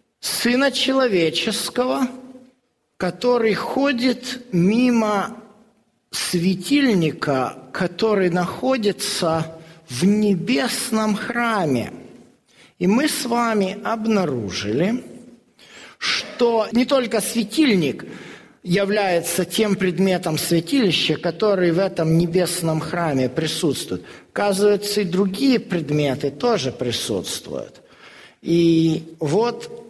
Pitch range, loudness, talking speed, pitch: 170-235 Hz, -20 LUFS, 75 wpm, 205 Hz